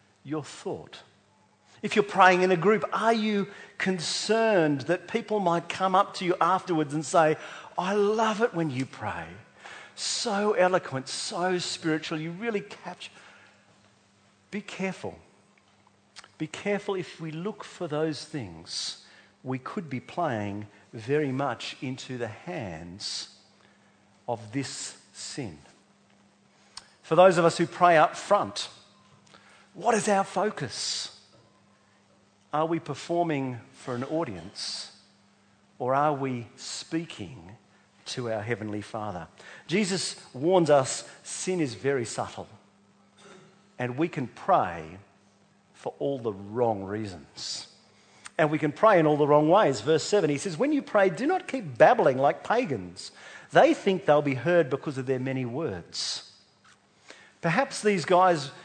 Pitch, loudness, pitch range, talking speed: 155 Hz, -27 LUFS, 120-185 Hz, 135 wpm